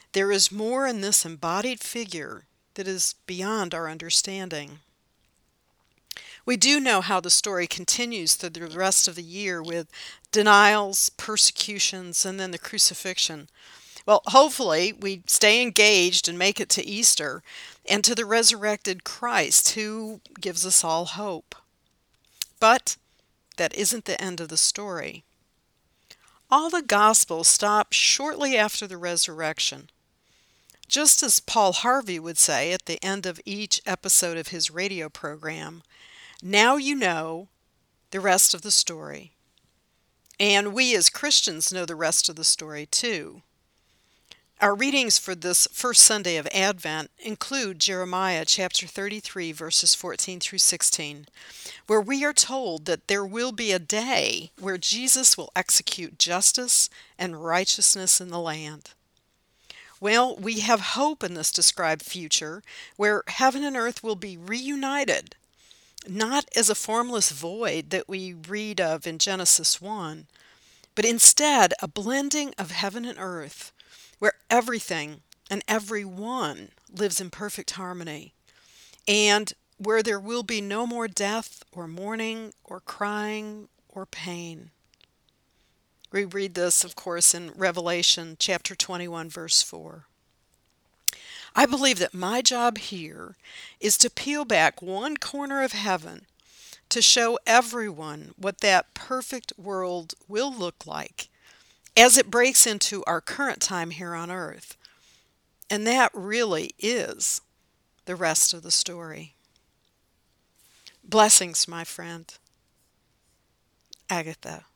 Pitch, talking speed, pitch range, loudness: 195 Hz, 135 wpm, 170-220 Hz, -22 LUFS